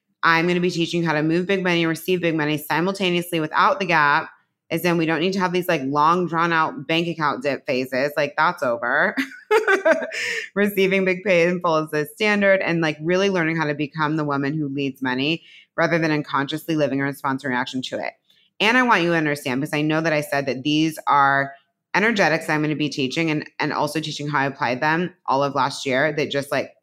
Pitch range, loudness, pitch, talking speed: 145-180 Hz, -21 LUFS, 160 Hz, 230 wpm